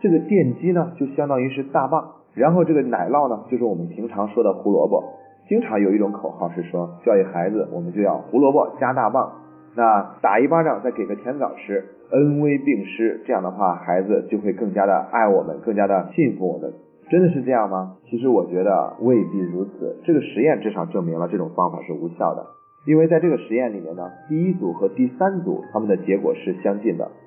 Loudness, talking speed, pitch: -21 LUFS, 325 characters per minute, 135 Hz